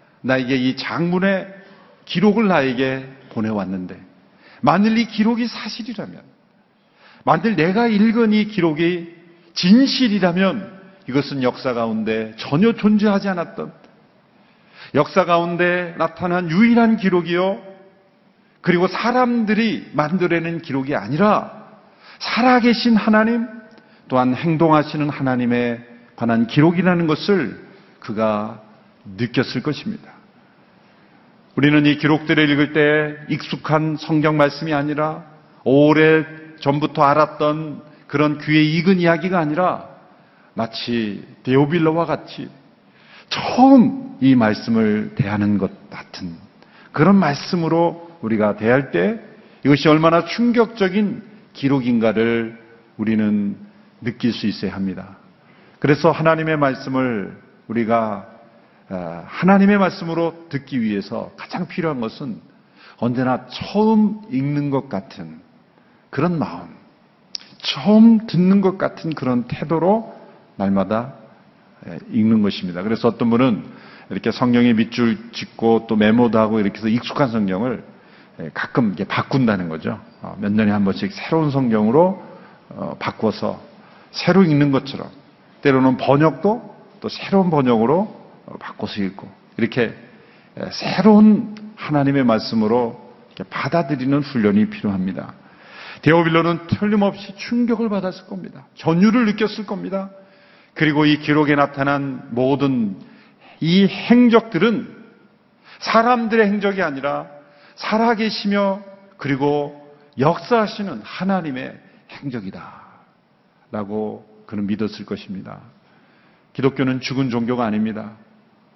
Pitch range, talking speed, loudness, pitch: 130-205 Hz, 260 characters per minute, -18 LUFS, 160 Hz